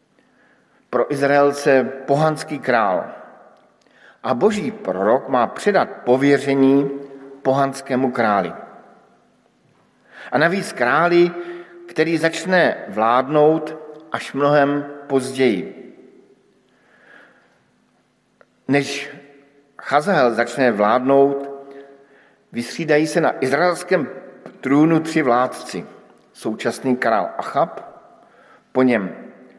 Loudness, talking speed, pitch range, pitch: -18 LUFS, 75 wpm, 135-160 Hz, 140 Hz